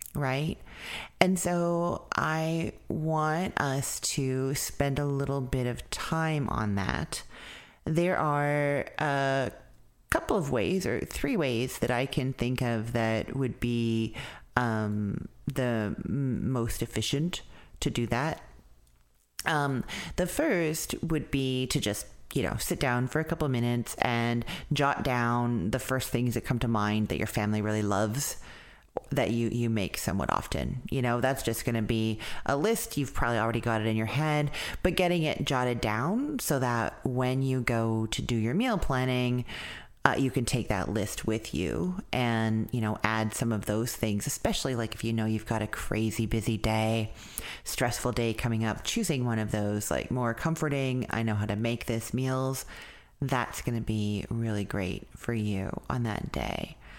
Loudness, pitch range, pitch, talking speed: -30 LUFS, 110-140 Hz, 120 Hz, 170 wpm